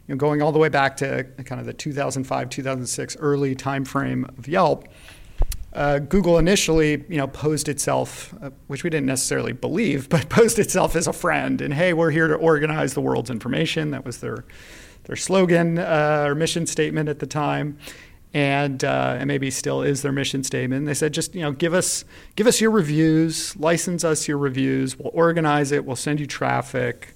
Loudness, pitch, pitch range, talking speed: -21 LUFS, 145 Hz, 135-165 Hz, 195 wpm